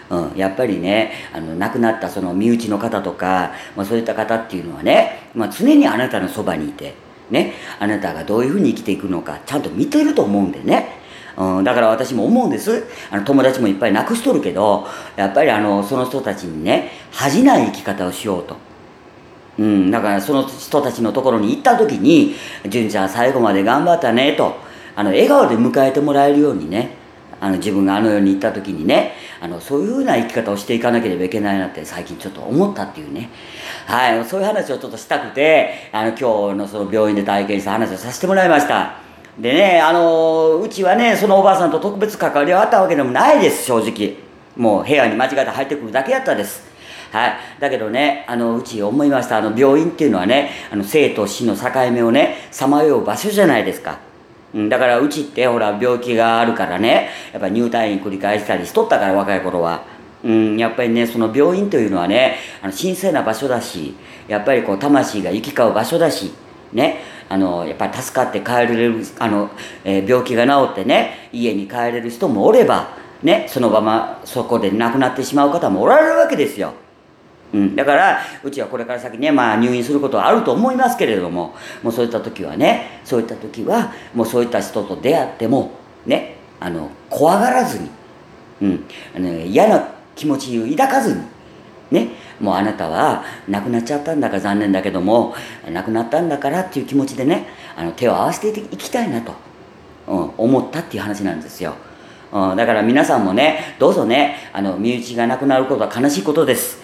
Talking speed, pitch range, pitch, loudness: 410 characters per minute, 100-140 Hz, 120 Hz, -17 LUFS